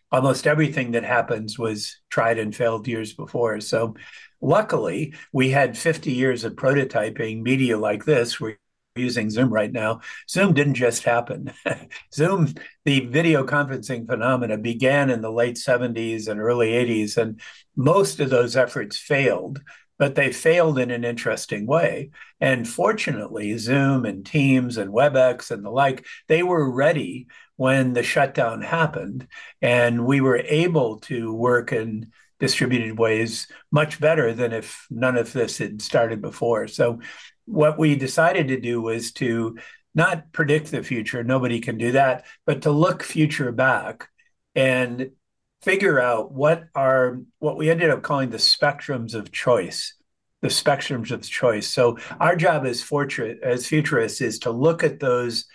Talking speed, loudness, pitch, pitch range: 150 wpm, -22 LUFS, 130 Hz, 115-145 Hz